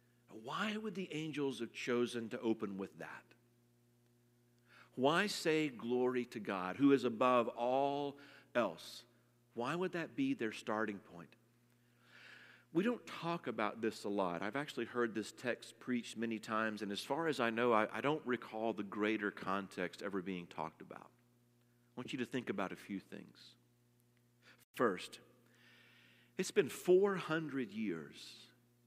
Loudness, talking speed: -38 LUFS, 150 wpm